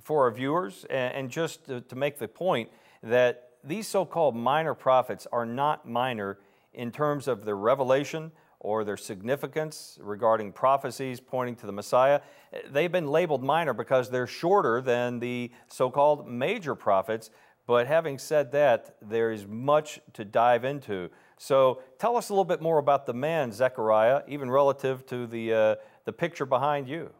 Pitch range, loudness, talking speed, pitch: 120-150 Hz, -27 LUFS, 165 wpm, 130 Hz